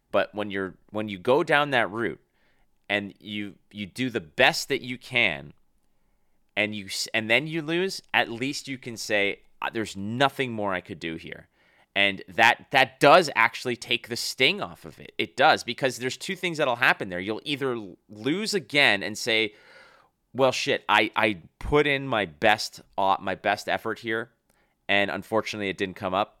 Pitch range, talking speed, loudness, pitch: 100-130 Hz, 180 wpm, -25 LUFS, 110 Hz